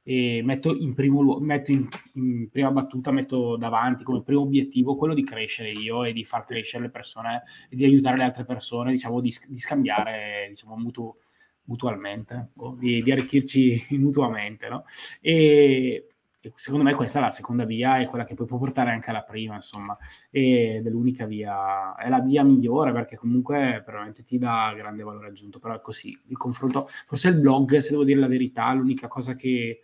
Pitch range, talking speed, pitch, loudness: 115-135 Hz, 195 wpm, 125 Hz, -24 LUFS